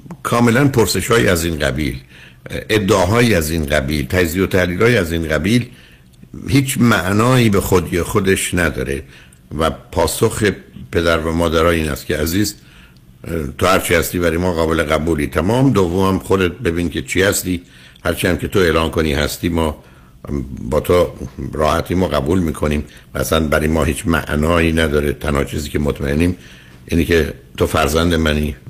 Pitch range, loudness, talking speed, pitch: 70-90 Hz, -16 LUFS, 155 wpm, 80 Hz